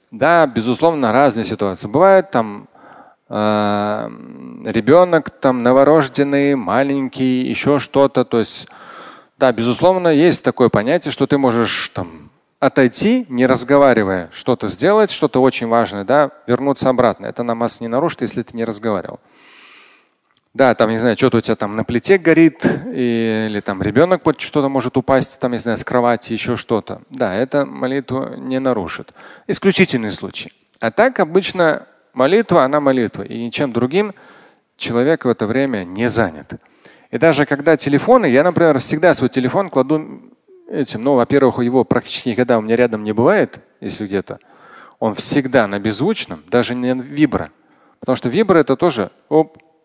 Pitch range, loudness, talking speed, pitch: 115-150 Hz, -16 LUFS, 150 wpm, 130 Hz